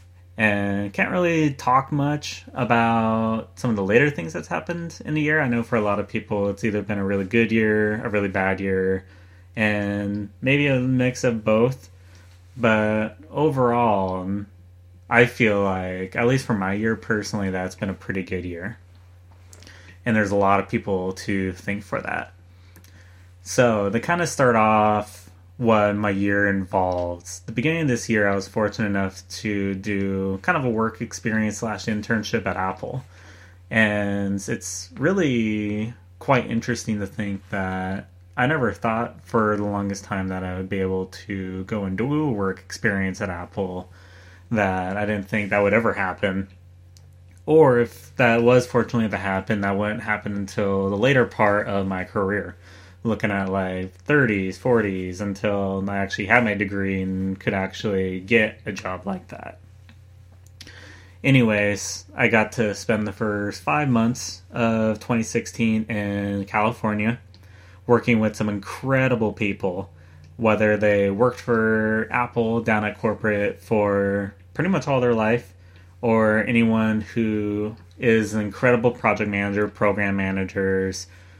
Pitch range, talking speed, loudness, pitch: 95-115 Hz, 155 wpm, -22 LUFS, 100 Hz